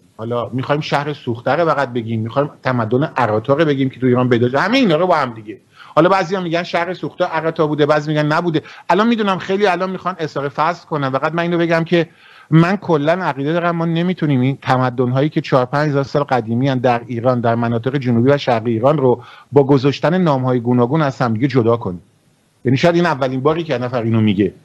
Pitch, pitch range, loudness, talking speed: 145 Hz, 125-165 Hz, -16 LUFS, 210 wpm